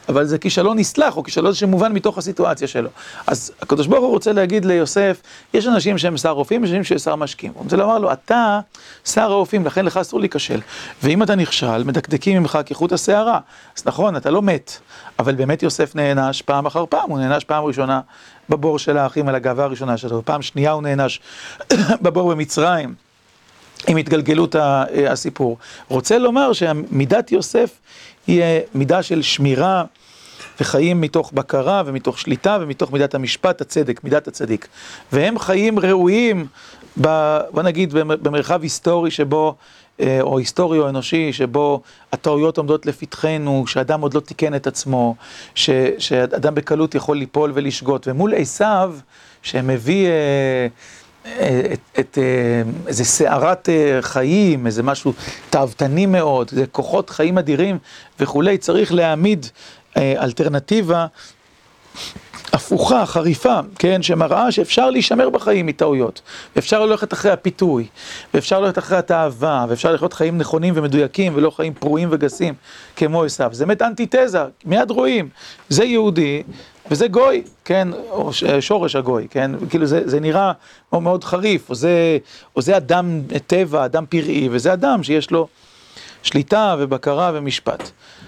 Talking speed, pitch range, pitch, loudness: 140 wpm, 140-185 Hz, 155 Hz, -17 LUFS